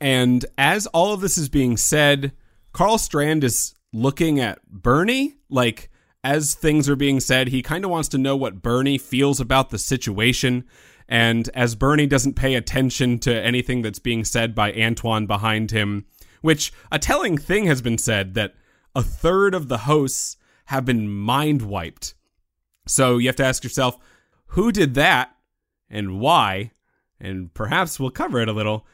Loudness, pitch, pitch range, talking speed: -20 LUFS, 125 Hz, 110-145 Hz, 170 wpm